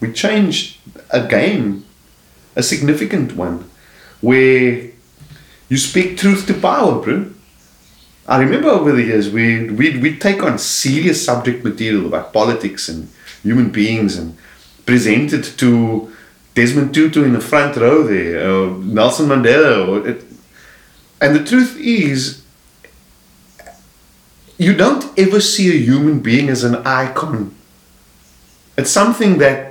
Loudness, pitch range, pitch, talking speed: -14 LUFS, 105-155 Hz, 125 Hz, 130 wpm